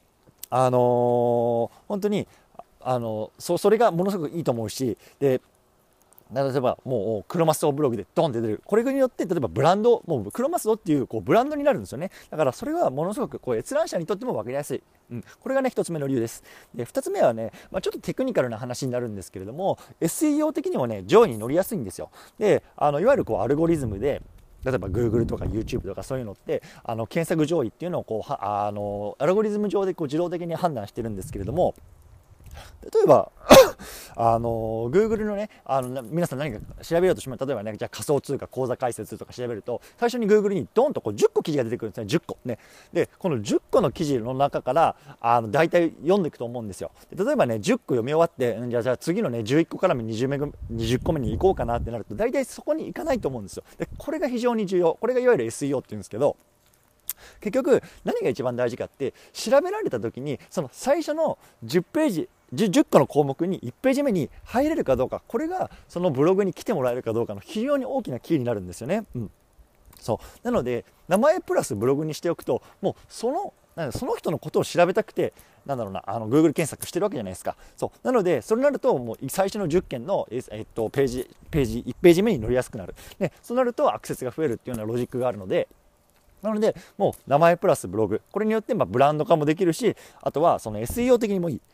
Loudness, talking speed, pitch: -24 LUFS, 460 characters per minute, 145 Hz